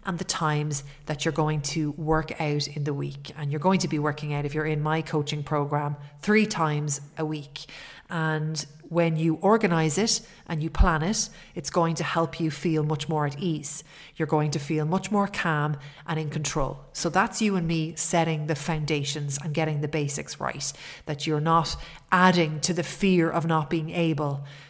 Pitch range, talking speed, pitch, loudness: 150-170 Hz, 200 wpm, 155 Hz, -26 LUFS